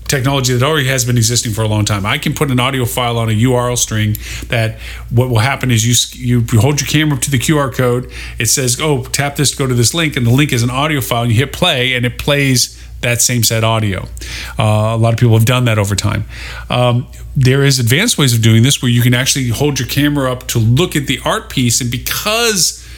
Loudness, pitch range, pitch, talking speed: -13 LUFS, 115-140 Hz, 125 Hz, 255 wpm